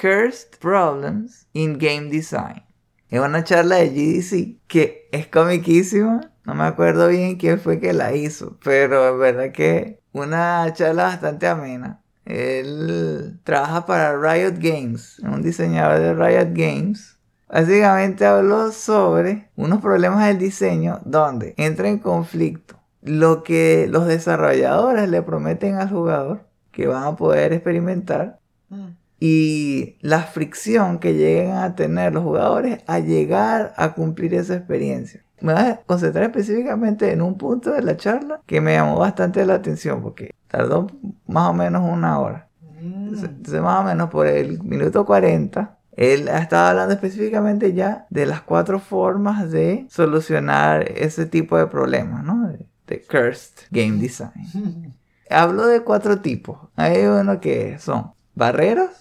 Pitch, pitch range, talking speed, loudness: 165 Hz, 130-195 Hz, 145 wpm, -19 LUFS